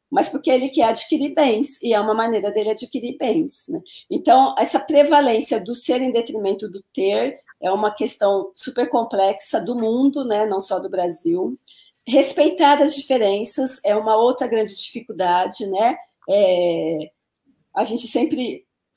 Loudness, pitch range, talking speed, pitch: -19 LUFS, 205-275 Hz, 150 wpm, 235 Hz